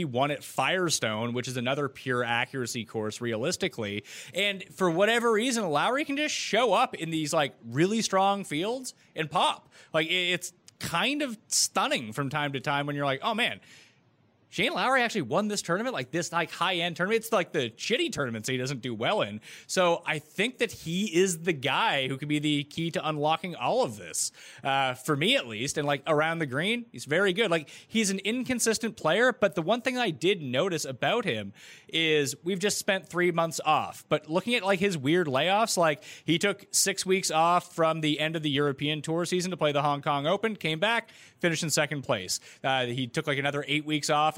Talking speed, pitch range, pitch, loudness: 210 wpm, 145-195 Hz, 160 Hz, -27 LUFS